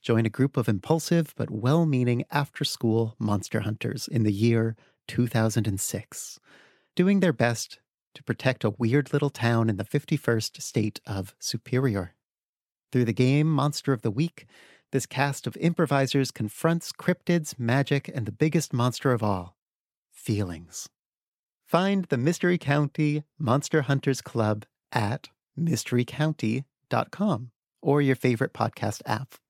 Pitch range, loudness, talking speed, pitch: 115-150 Hz, -26 LUFS, 135 wpm, 130 Hz